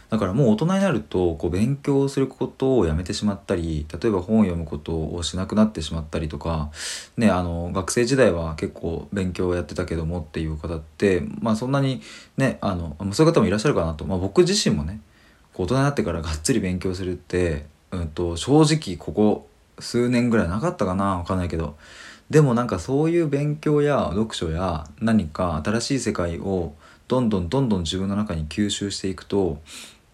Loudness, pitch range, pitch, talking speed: -23 LUFS, 80-115 Hz, 95 Hz, 390 characters per minute